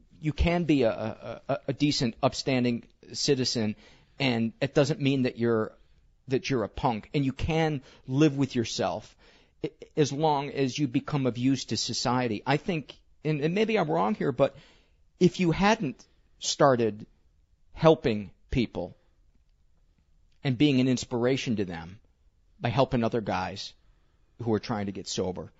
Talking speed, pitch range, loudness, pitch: 150 wpm, 105-145 Hz, -28 LUFS, 125 Hz